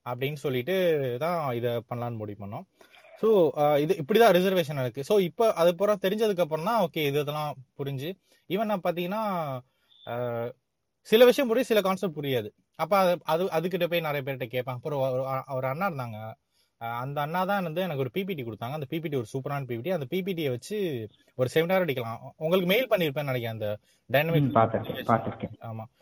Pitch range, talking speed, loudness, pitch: 125-185 Hz, 165 wpm, -27 LUFS, 150 Hz